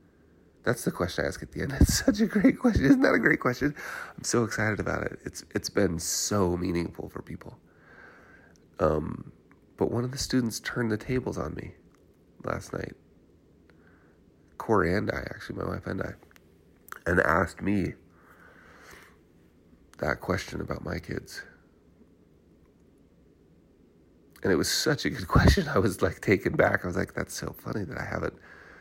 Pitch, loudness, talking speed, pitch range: 90 Hz, -28 LUFS, 165 wpm, 85-120 Hz